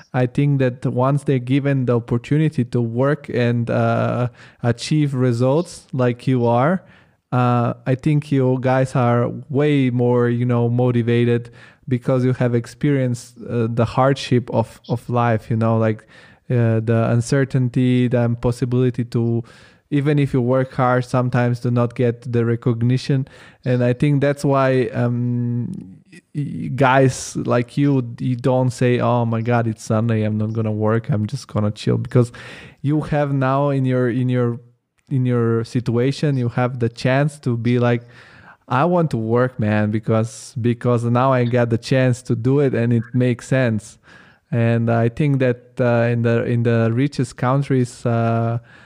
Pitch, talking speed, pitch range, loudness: 125 Hz, 160 wpm, 120-130 Hz, -19 LUFS